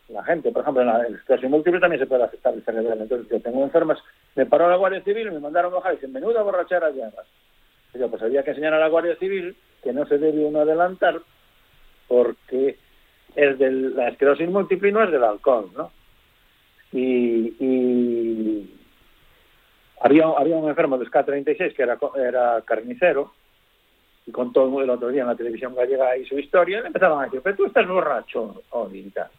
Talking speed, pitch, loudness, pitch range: 190 wpm, 140 Hz, -21 LUFS, 125-170 Hz